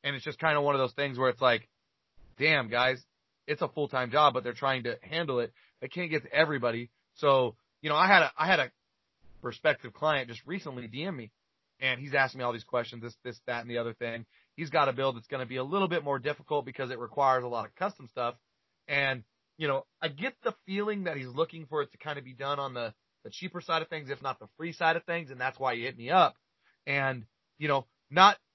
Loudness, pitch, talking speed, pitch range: -30 LUFS, 135 Hz, 255 wpm, 120-155 Hz